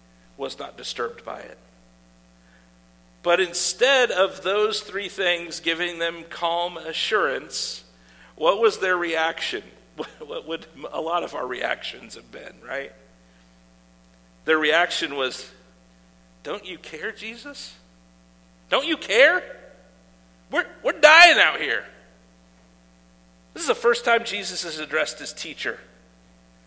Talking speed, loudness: 120 wpm, -22 LUFS